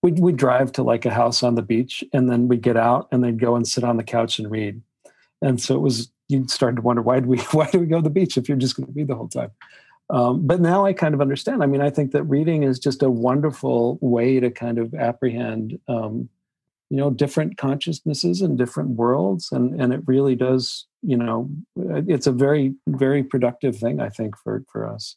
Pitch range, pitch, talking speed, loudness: 120-145 Hz, 130 Hz, 240 wpm, -21 LUFS